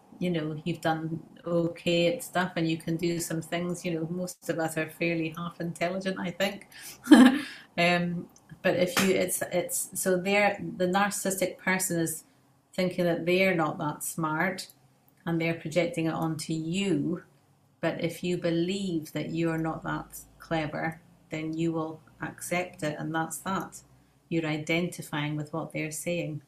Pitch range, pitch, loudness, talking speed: 160-180 Hz, 170 Hz, -29 LUFS, 165 wpm